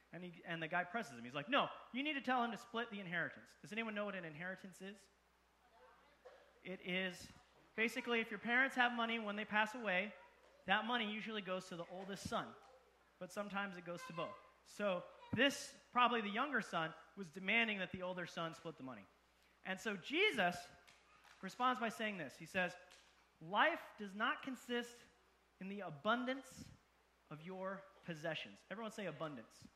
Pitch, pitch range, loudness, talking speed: 200 Hz, 180-235 Hz, -41 LUFS, 180 wpm